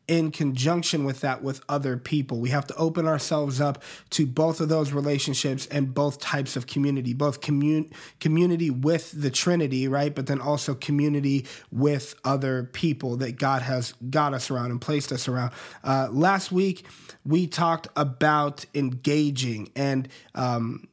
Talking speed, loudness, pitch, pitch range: 160 wpm, -25 LUFS, 145 Hz, 135-155 Hz